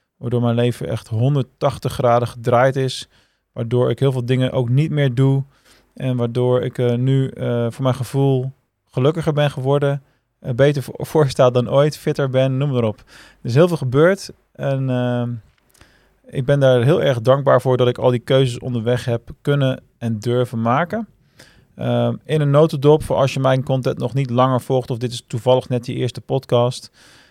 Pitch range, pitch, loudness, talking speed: 120-140 Hz, 130 Hz, -18 LUFS, 185 wpm